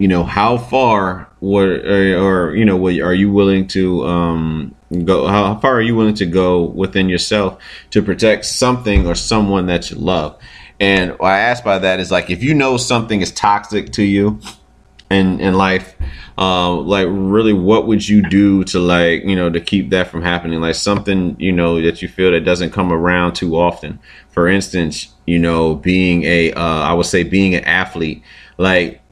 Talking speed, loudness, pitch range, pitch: 195 wpm, -14 LUFS, 85-100 Hz, 95 Hz